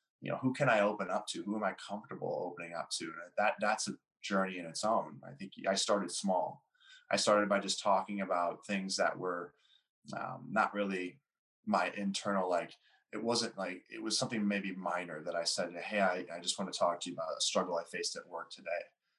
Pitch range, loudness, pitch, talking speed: 95-115 Hz, -35 LUFS, 100 Hz, 220 wpm